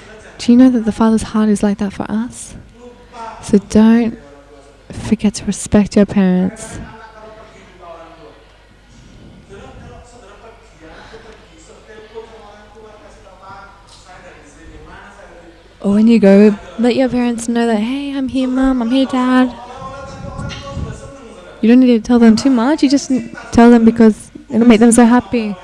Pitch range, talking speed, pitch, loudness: 210-245 Hz, 125 wpm, 225 Hz, -12 LUFS